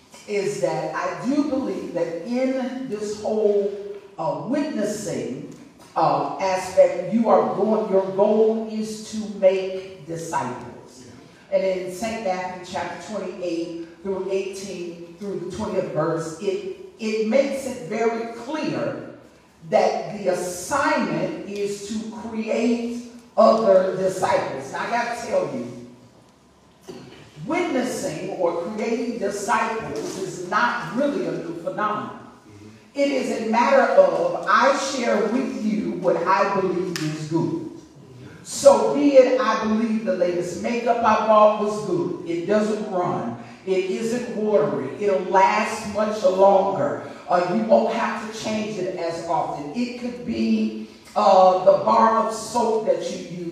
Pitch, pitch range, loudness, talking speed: 205 Hz, 185-235 Hz, -22 LUFS, 135 wpm